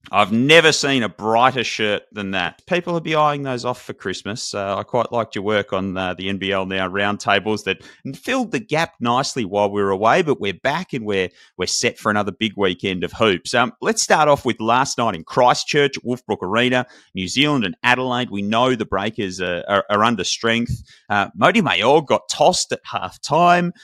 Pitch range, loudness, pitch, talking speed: 100-135 Hz, -19 LUFS, 115 Hz, 205 wpm